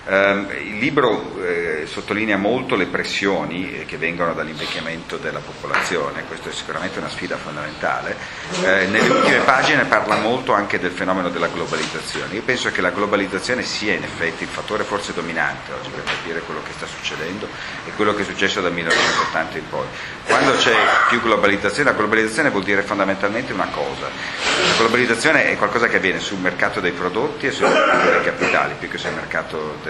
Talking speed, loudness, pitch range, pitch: 185 wpm, -19 LUFS, 85-100 Hz, 95 Hz